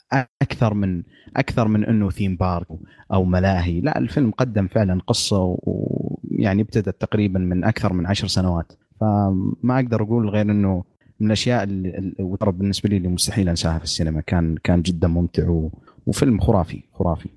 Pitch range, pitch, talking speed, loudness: 90-110 Hz, 95 Hz, 155 wpm, -21 LUFS